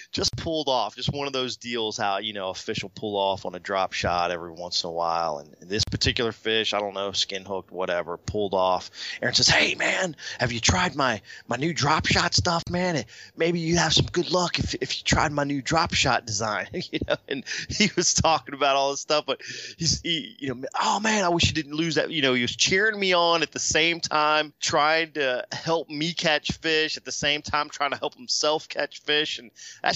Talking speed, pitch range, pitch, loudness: 235 wpm, 105-160 Hz, 140 Hz, -24 LUFS